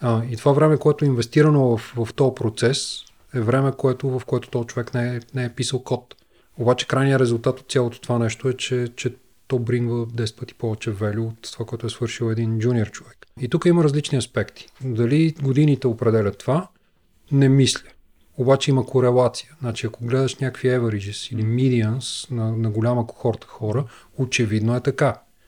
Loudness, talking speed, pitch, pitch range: -22 LUFS, 180 wpm, 125 Hz, 115-135 Hz